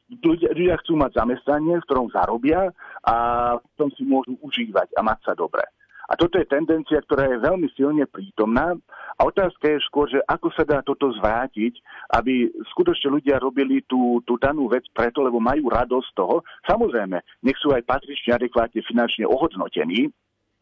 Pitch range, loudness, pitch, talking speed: 120-160 Hz, -22 LUFS, 140 Hz, 170 wpm